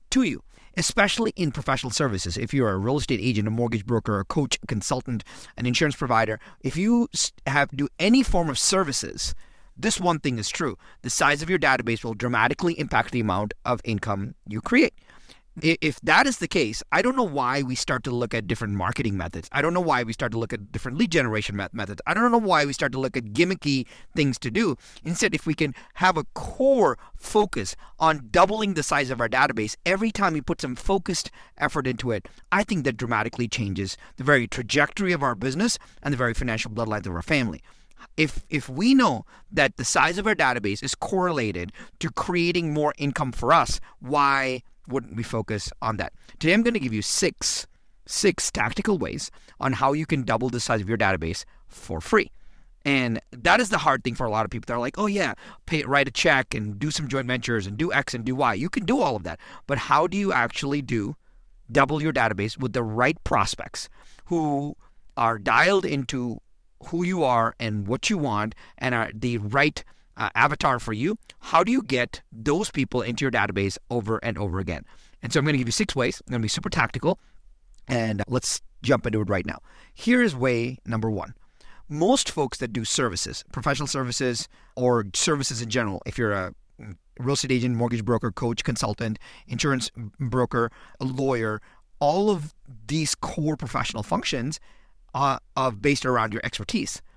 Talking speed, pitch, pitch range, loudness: 205 wpm, 130 Hz, 115-150 Hz, -24 LUFS